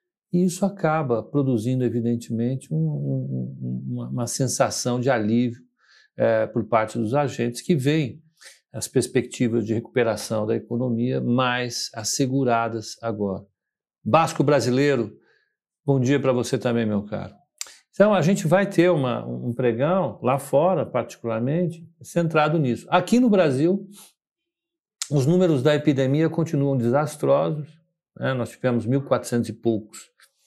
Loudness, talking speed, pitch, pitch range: -23 LUFS, 130 wpm, 130 Hz, 115-160 Hz